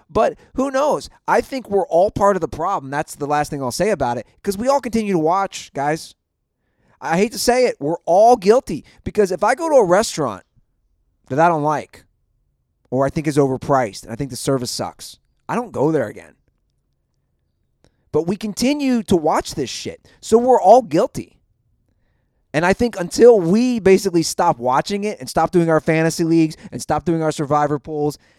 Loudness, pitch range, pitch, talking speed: -18 LUFS, 145-210 Hz, 165 Hz, 195 wpm